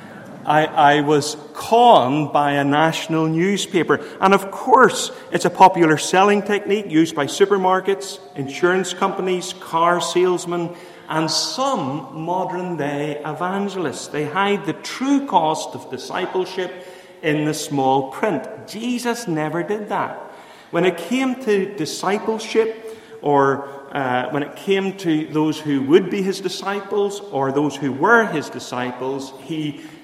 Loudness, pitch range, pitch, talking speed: -19 LUFS, 150-195 Hz, 180 Hz, 135 wpm